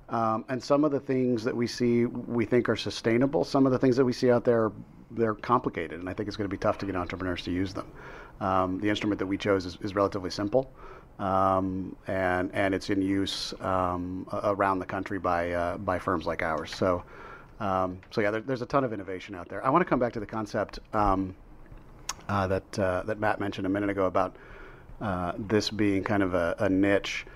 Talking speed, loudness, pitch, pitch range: 225 wpm, -28 LUFS, 100 Hz, 95-115 Hz